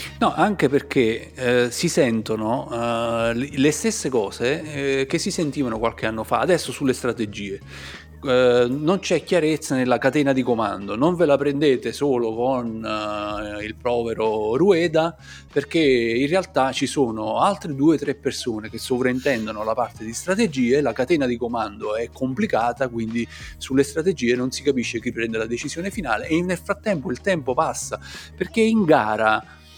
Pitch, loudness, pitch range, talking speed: 125 Hz, -22 LUFS, 115-150 Hz, 160 wpm